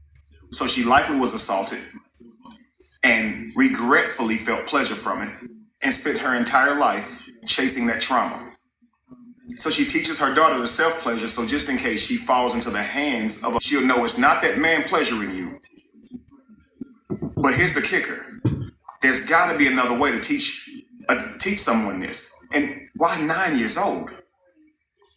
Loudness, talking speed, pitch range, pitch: -21 LUFS, 155 wpm, 195-275 Hz, 245 Hz